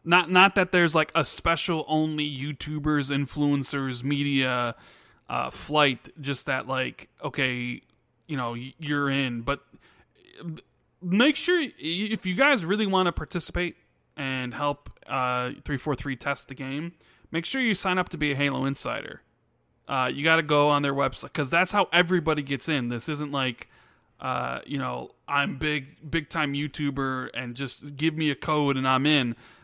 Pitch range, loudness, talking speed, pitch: 135-165 Hz, -26 LUFS, 170 wpm, 145 Hz